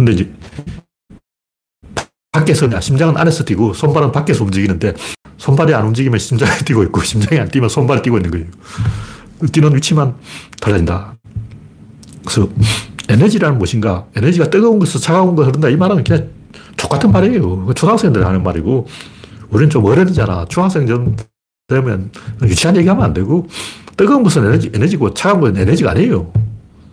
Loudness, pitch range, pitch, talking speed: -13 LUFS, 105-155 Hz, 120 Hz, 375 characters per minute